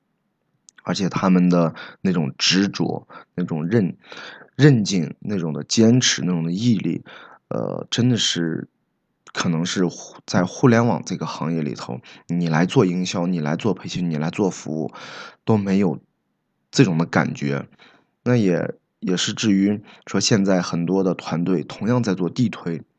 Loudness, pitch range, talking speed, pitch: -21 LUFS, 85-100 Hz, 220 characters per minute, 90 Hz